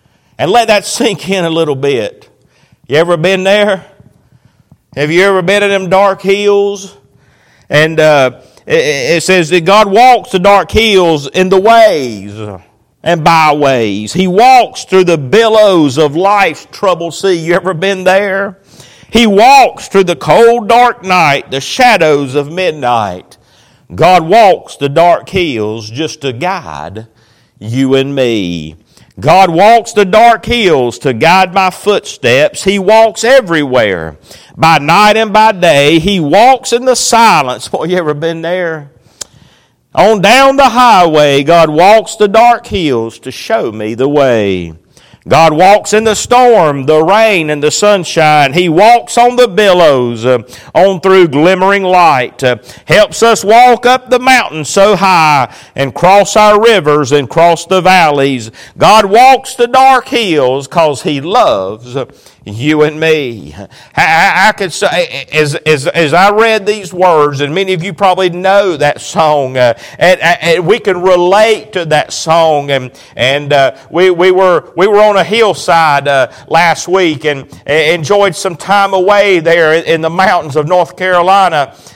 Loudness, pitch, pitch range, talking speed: -8 LUFS, 180 Hz, 145-205 Hz, 155 wpm